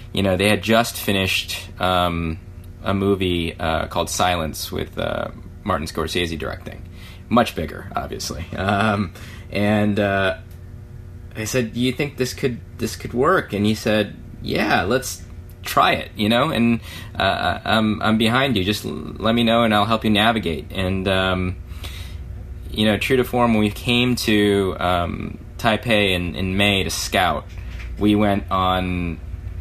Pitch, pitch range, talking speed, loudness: 95 Hz, 90-110 Hz, 160 wpm, -20 LUFS